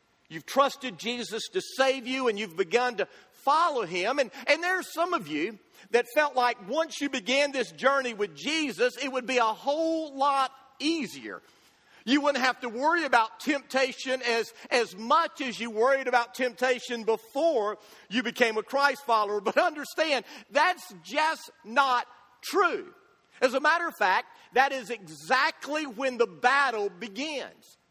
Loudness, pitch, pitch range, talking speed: -27 LUFS, 260 Hz, 235-290 Hz, 160 wpm